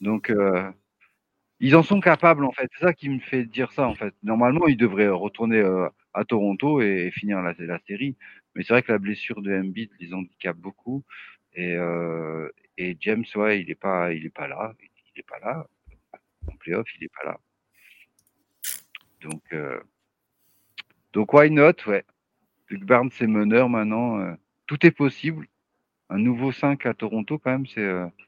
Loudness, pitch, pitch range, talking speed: -23 LUFS, 110 Hz, 95-130 Hz, 185 wpm